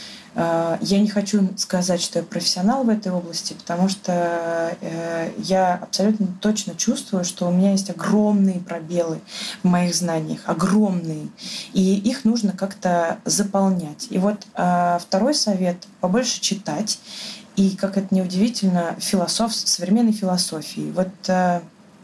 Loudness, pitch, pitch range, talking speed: -21 LUFS, 190 Hz, 175-210 Hz, 125 wpm